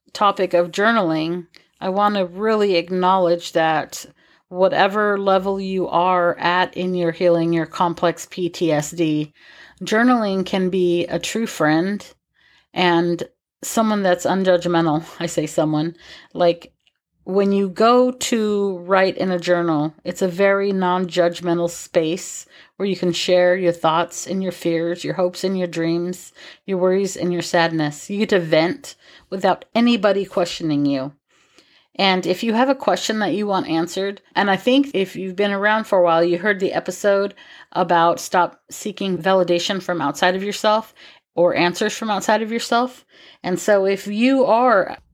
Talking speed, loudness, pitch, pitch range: 155 wpm, -19 LUFS, 180 Hz, 170-200 Hz